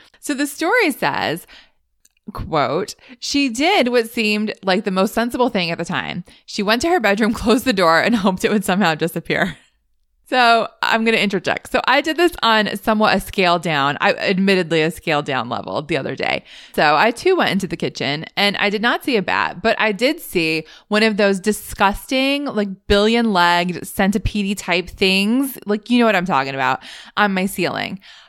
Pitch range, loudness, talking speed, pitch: 180-235 Hz, -18 LUFS, 195 wpm, 210 Hz